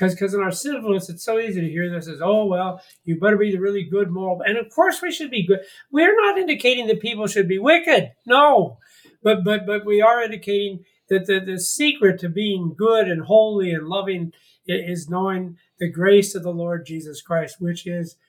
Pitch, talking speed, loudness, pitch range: 195 Hz, 210 wpm, -20 LUFS, 175-220 Hz